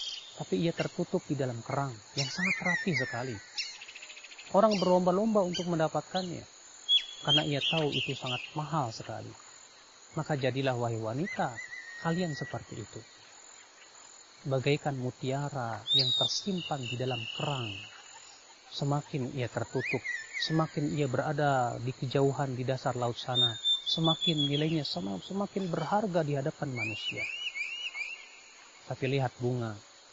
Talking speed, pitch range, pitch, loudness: 115 wpm, 125-165 Hz, 145 Hz, -31 LUFS